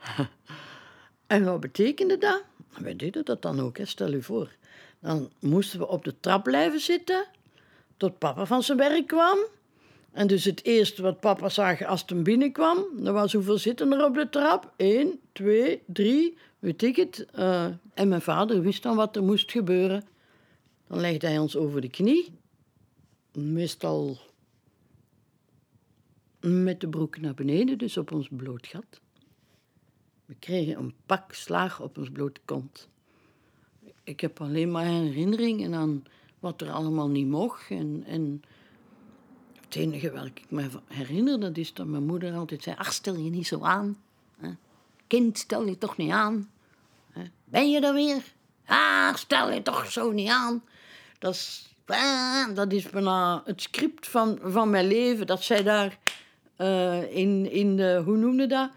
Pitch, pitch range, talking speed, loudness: 195 Hz, 160-235 Hz, 160 wpm, -26 LUFS